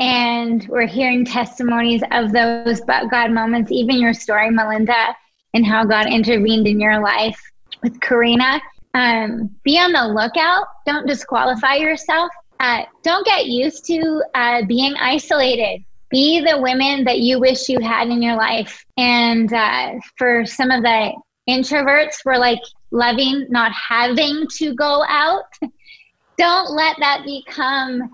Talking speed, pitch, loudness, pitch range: 145 wpm, 250 Hz, -16 LUFS, 230-290 Hz